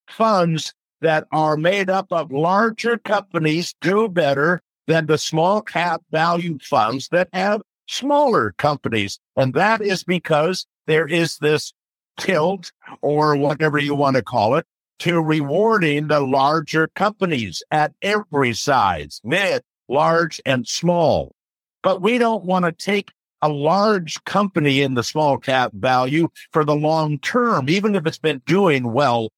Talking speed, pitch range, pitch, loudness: 145 wpm, 145-190 Hz, 160 Hz, -19 LUFS